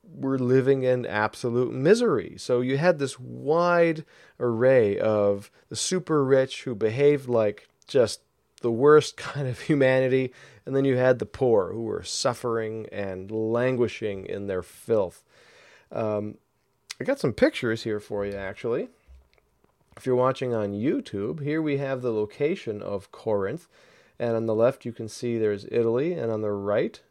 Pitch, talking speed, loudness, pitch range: 120 Hz, 160 wpm, -25 LUFS, 110-135 Hz